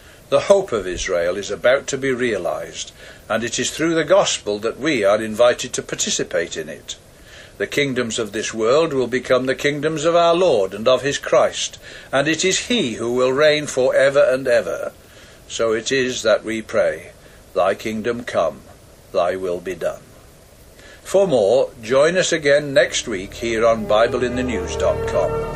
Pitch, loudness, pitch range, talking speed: 130 Hz, -19 LUFS, 115-155 Hz, 170 wpm